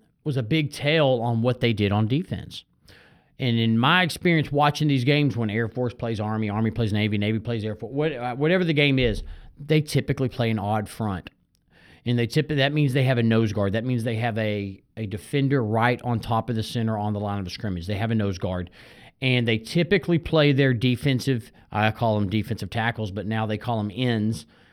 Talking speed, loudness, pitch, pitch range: 220 wpm, -24 LUFS, 120 Hz, 110-135 Hz